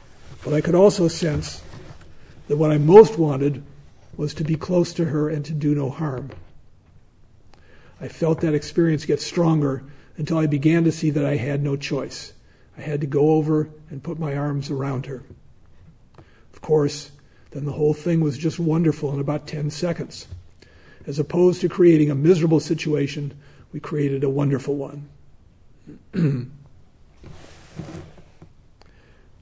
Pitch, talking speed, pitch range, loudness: 145 Hz, 150 wpm, 135-155 Hz, -21 LUFS